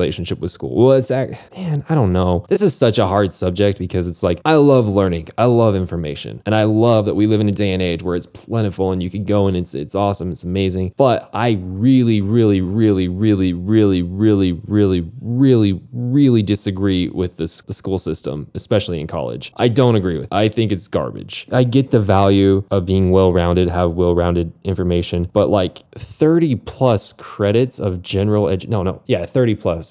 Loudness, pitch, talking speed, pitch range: -17 LUFS, 100 Hz, 205 wpm, 90-115 Hz